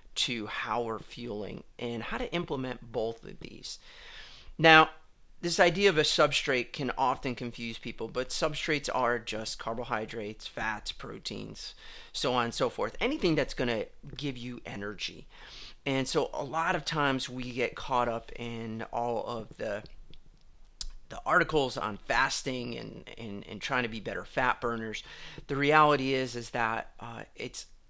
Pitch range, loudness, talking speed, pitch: 115-155 Hz, -30 LUFS, 160 wpm, 125 Hz